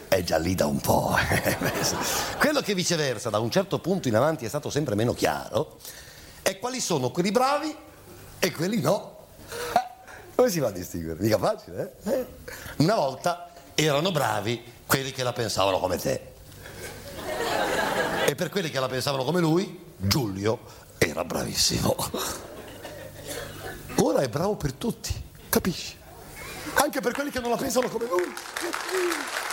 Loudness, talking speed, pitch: -26 LUFS, 150 wpm, 170 Hz